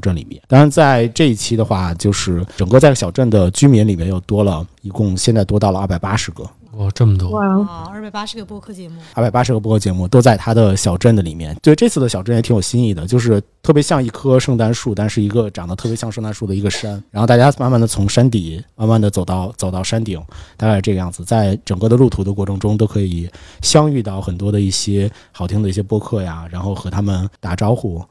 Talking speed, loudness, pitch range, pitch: 370 characters per minute, -15 LUFS, 95-120 Hz, 105 Hz